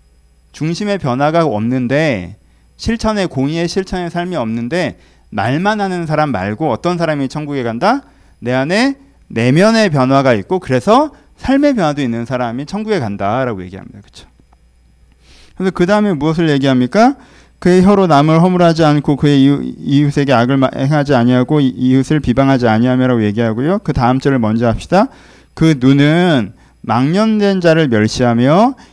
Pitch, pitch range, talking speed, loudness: 140 Hz, 120-175 Hz, 335 characters per minute, -13 LUFS